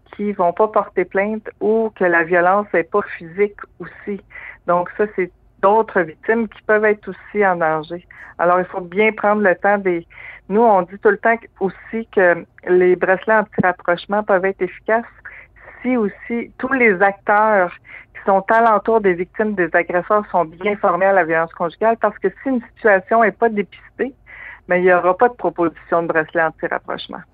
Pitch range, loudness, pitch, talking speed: 180-215 Hz, -17 LUFS, 195 Hz, 185 wpm